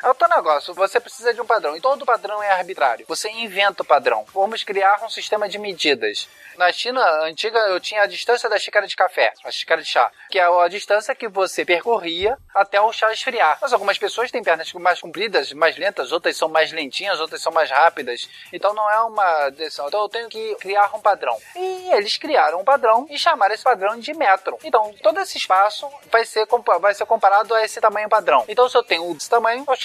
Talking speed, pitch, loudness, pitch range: 215 wpm, 215 Hz, -19 LUFS, 195-245 Hz